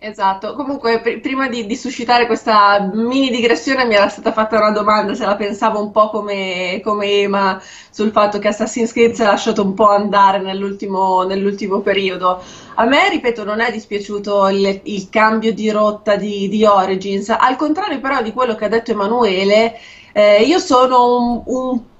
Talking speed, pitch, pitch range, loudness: 180 wpm, 215 Hz, 200-235 Hz, -15 LUFS